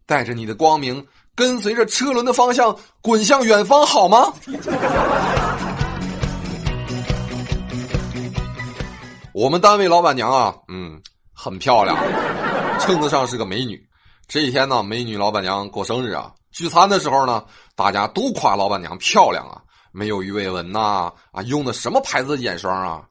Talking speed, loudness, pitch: 220 characters per minute, -18 LUFS, 120 Hz